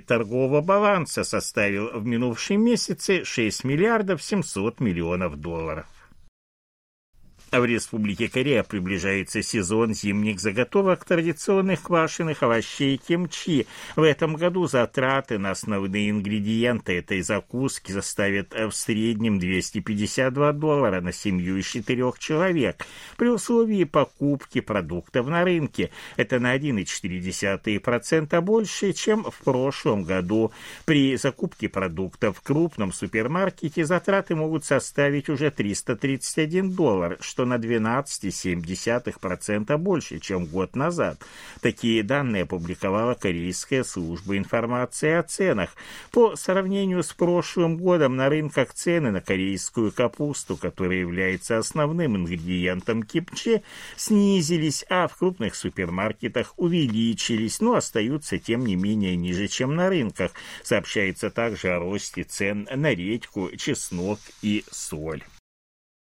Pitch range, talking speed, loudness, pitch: 100-160 Hz, 110 wpm, -24 LUFS, 120 Hz